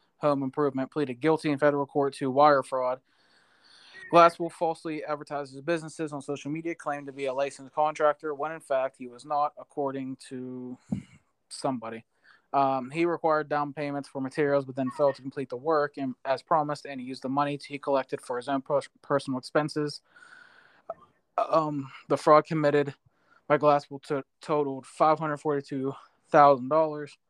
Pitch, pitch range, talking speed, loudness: 145 Hz, 135-150 Hz, 155 wpm, -28 LUFS